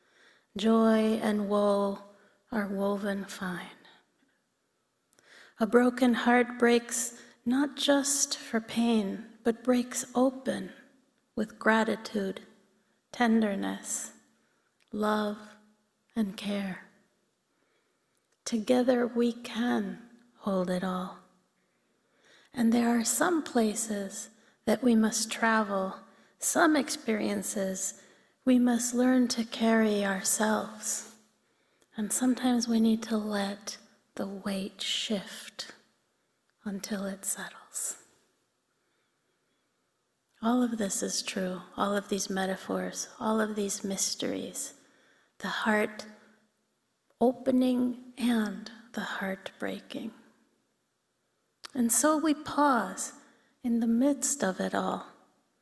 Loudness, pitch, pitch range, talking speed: -29 LUFS, 220 Hz, 200-245 Hz, 95 wpm